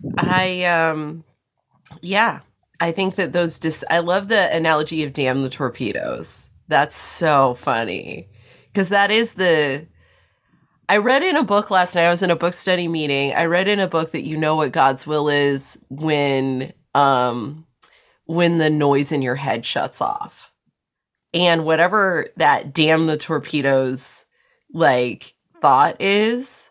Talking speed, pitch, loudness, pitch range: 155 wpm, 160 Hz, -19 LUFS, 135-175 Hz